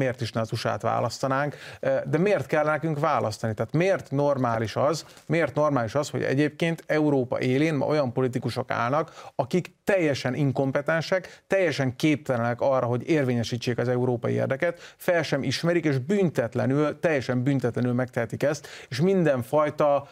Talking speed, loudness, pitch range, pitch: 145 wpm, -25 LUFS, 125-155 Hz, 140 Hz